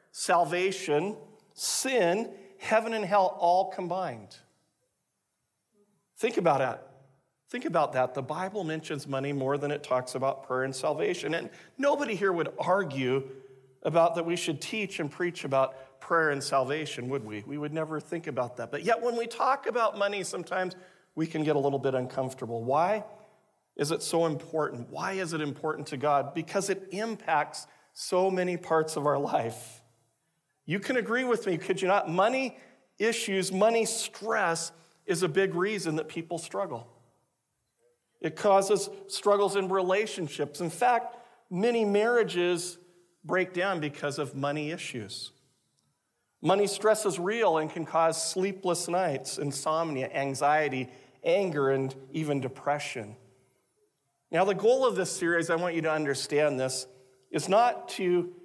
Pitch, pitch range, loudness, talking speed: 165 Hz, 140-195 Hz, -29 LUFS, 150 wpm